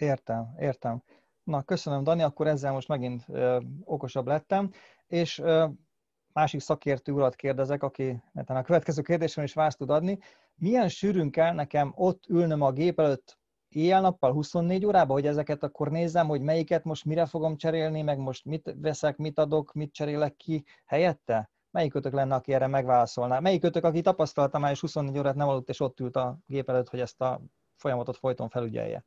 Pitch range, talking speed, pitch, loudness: 135-165 Hz, 175 wpm, 150 Hz, -28 LUFS